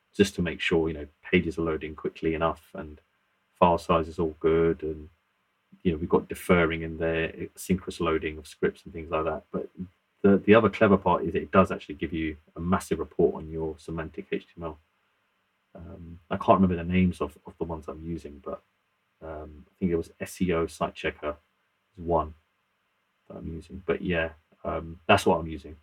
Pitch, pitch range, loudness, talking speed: 80 Hz, 80-85 Hz, -27 LUFS, 195 wpm